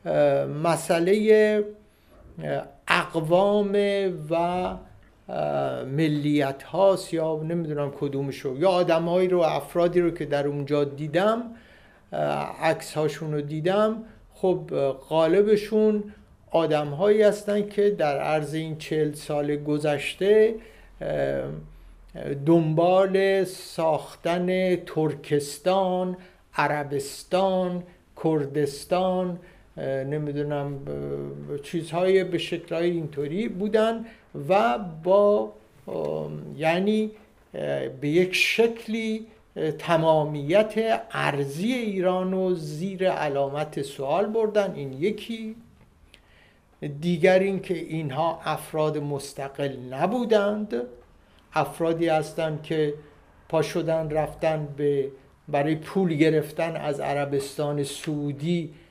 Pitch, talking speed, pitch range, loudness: 160 Hz, 80 wpm, 145-185 Hz, -25 LUFS